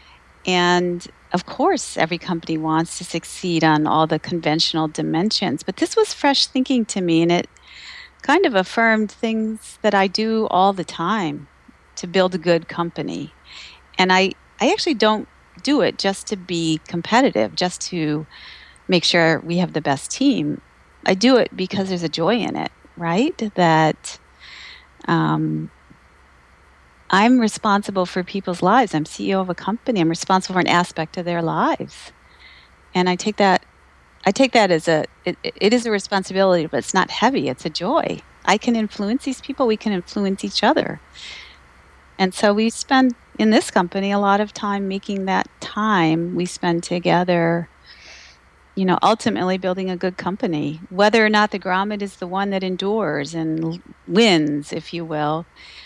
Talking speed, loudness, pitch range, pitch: 170 wpm, -19 LUFS, 160-210 Hz, 185 Hz